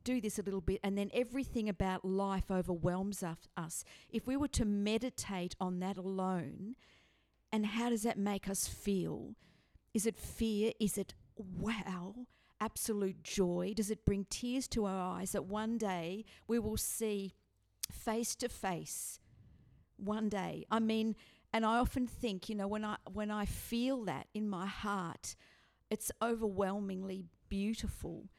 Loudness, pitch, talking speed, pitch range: -38 LUFS, 205 Hz, 155 wpm, 190-225 Hz